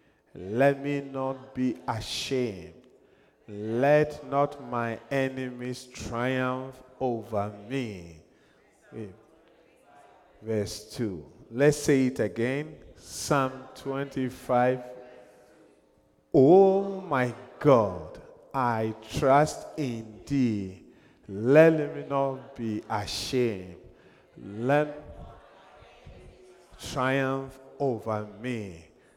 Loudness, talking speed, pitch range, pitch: -27 LUFS, 75 wpm, 110-135 Hz, 125 Hz